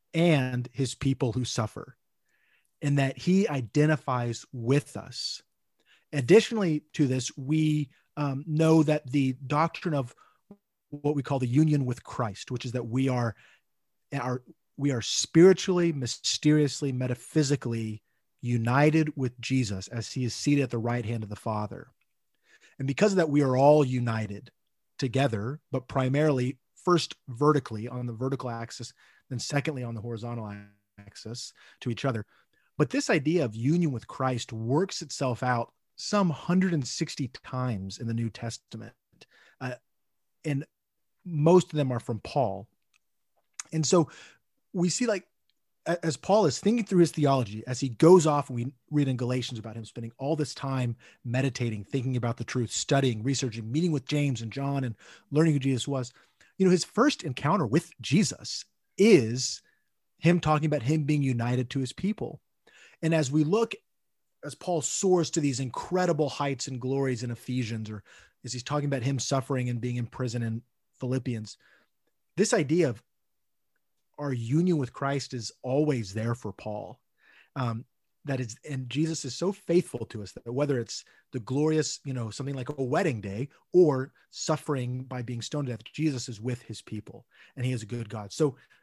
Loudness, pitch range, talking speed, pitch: -28 LUFS, 120-155 Hz, 165 wpm, 135 Hz